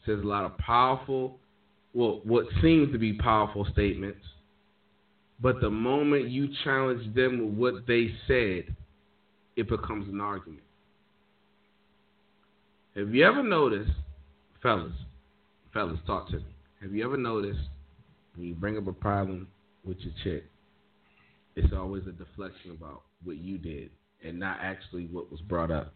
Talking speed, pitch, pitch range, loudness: 145 wpm, 100 Hz, 85-110 Hz, -29 LUFS